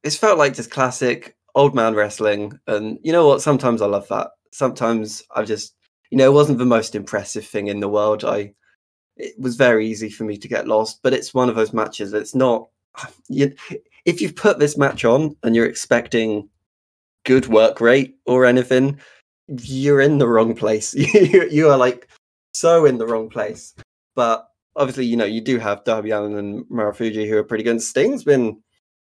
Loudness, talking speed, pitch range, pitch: -18 LUFS, 195 wpm, 105-135 Hz, 115 Hz